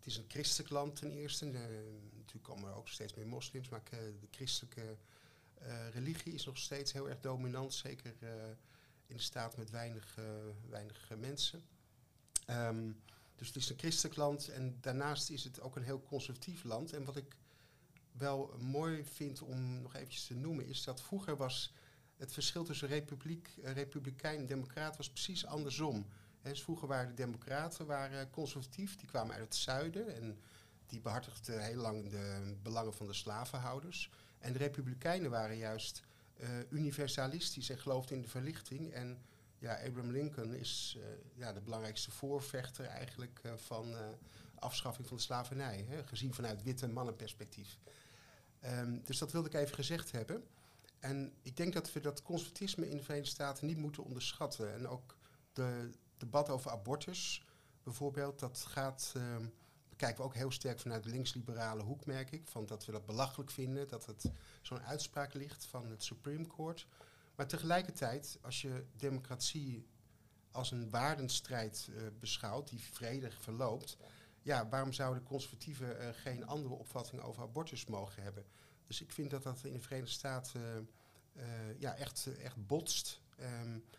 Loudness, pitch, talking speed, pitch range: -43 LUFS, 130 Hz, 170 wpm, 115-145 Hz